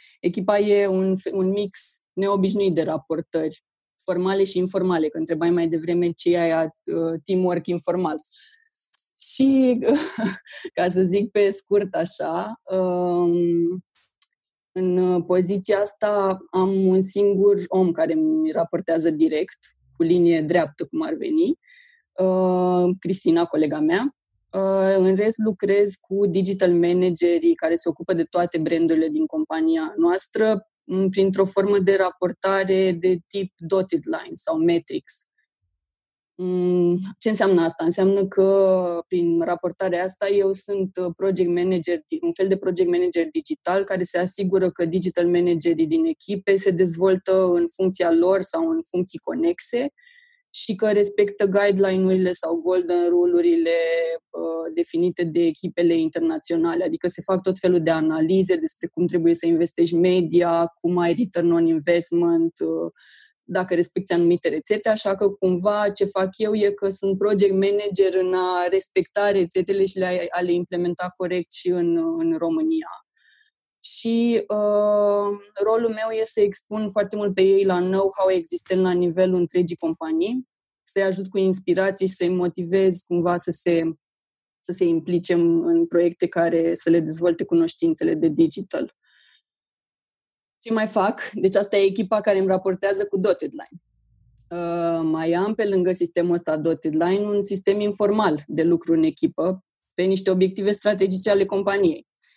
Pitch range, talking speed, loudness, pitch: 175-205 Hz, 140 wpm, -21 LUFS, 185 Hz